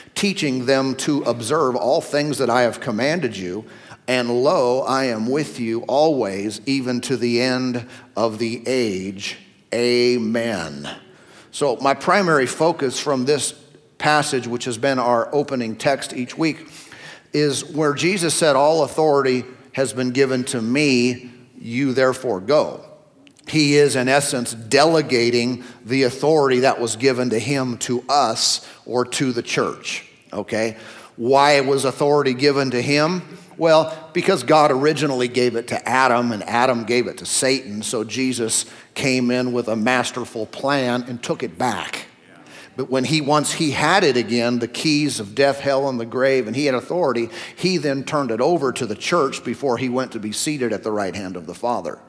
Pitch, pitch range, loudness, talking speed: 130 Hz, 120-145 Hz, -19 LUFS, 170 wpm